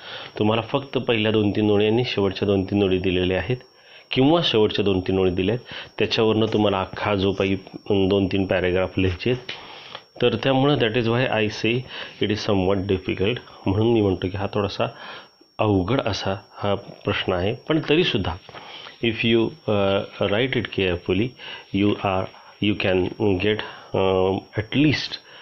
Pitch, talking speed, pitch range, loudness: 105 Hz, 150 wpm, 95-115 Hz, -22 LUFS